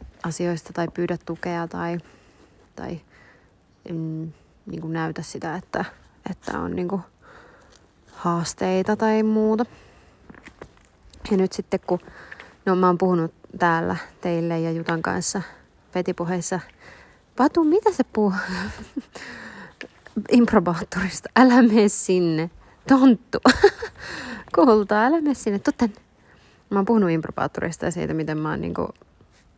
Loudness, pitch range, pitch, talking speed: -22 LUFS, 170-220 Hz, 185 Hz, 115 wpm